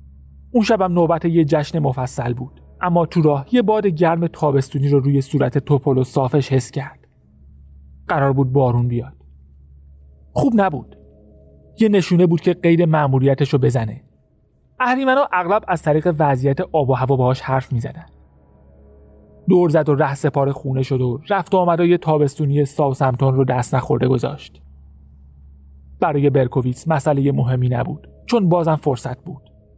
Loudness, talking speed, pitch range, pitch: -18 LUFS, 155 wpm, 120-165 Hz, 140 Hz